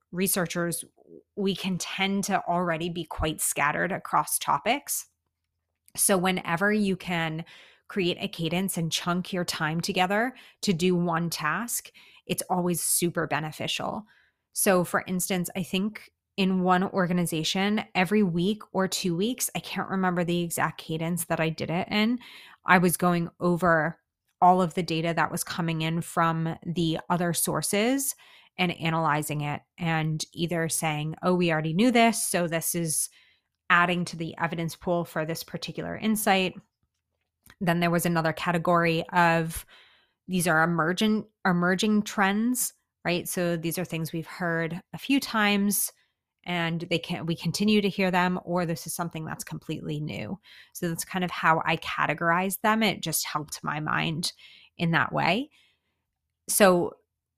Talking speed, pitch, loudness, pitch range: 155 wpm, 175 Hz, -26 LUFS, 165-190 Hz